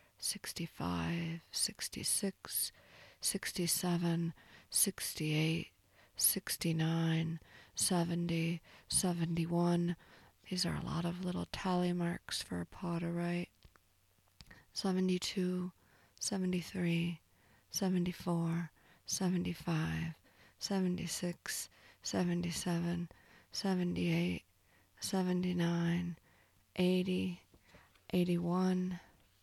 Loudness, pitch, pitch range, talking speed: -36 LUFS, 170 Hz, 160-180 Hz, 60 wpm